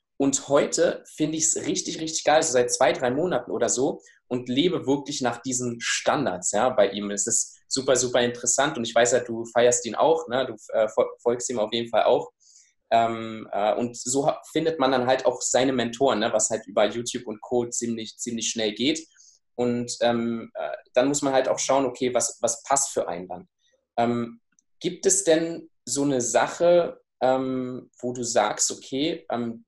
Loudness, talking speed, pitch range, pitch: -24 LUFS, 200 wpm, 115-140 Hz, 125 Hz